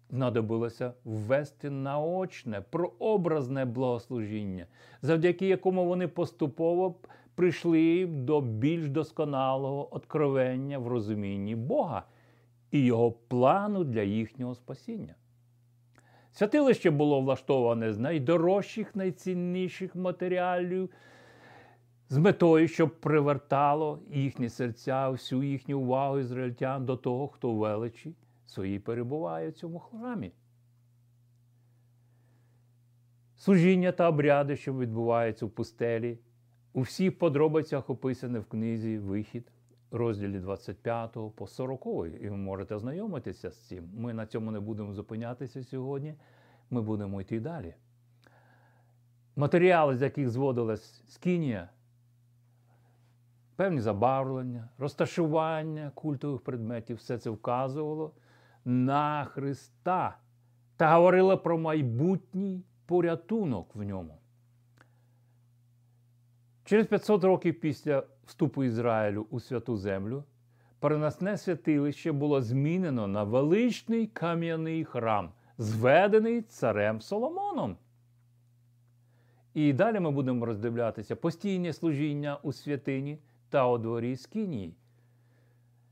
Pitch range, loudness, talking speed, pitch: 120-155 Hz, -30 LUFS, 95 wpm, 125 Hz